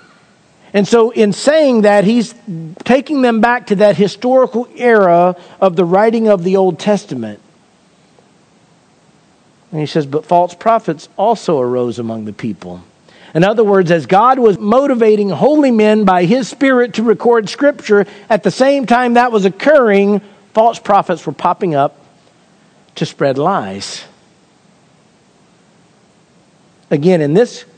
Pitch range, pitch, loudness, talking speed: 175-230 Hz, 205 Hz, -12 LUFS, 140 wpm